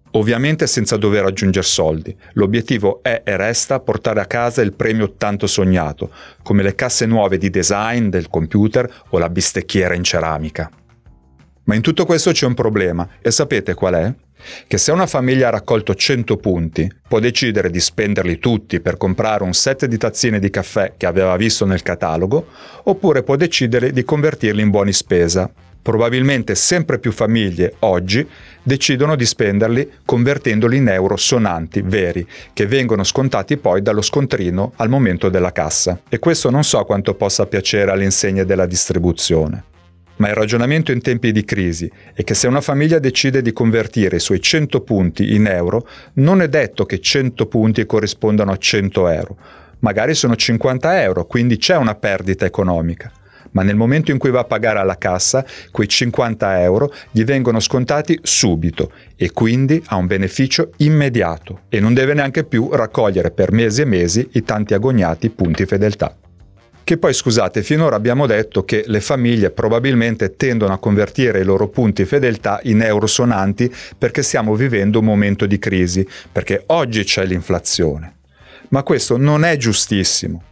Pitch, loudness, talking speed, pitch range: 110 Hz, -16 LUFS, 165 wpm, 95-125 Hz